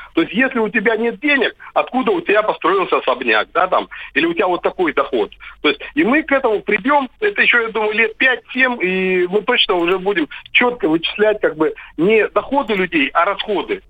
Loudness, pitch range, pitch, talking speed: -16 LUFS, 215-320 Hz, 255 Hz, 205 wpm